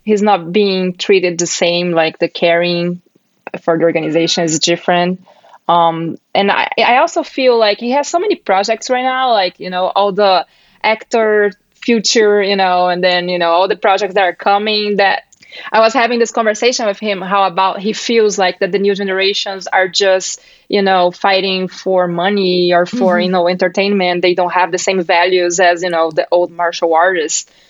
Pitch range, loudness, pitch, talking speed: 175-205 Hz, -13 LUFS, 190 Hz, 195 wpm